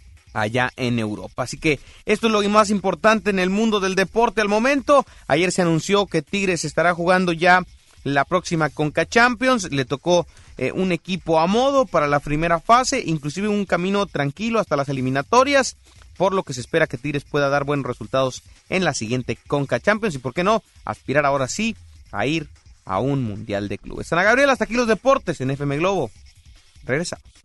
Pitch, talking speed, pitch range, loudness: 165 Hz, 190 wpm, 130-205 Hz, -20 LUFS